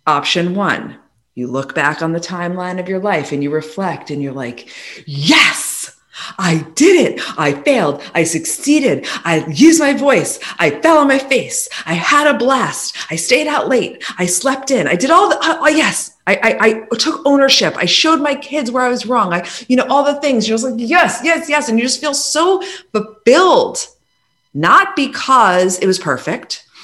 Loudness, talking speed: -14 LUFS, 195 wpm